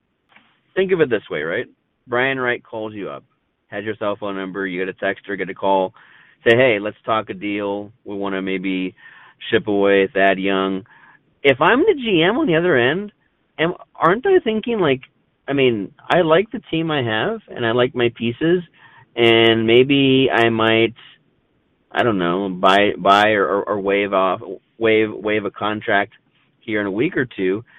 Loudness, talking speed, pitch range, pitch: -18 LUFS, 190 wpm, 100-130 Hz, 110 Hz